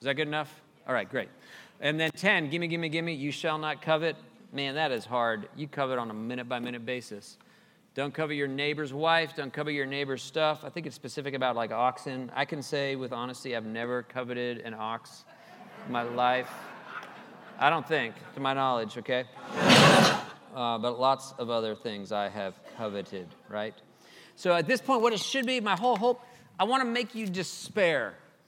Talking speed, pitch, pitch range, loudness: 195 wpm, 140 Hz, 125-165 Hz, -29 LUFS